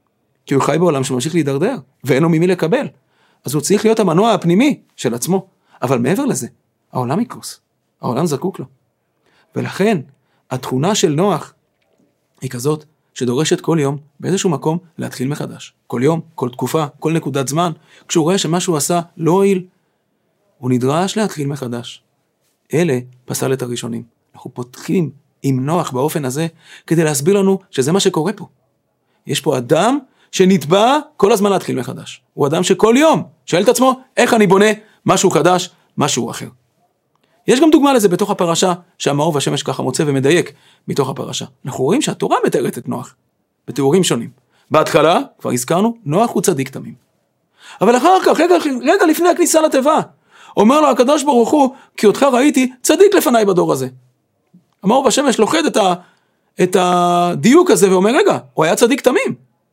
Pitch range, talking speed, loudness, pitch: 145-215 Hz, 160 wpm, -15 LUFS, 180 Hz